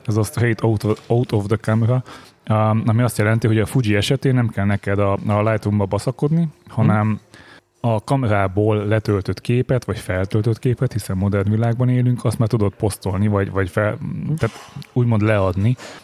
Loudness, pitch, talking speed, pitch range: -19 LUFS, 110 Hz, 155 wpm, 105-125 Hz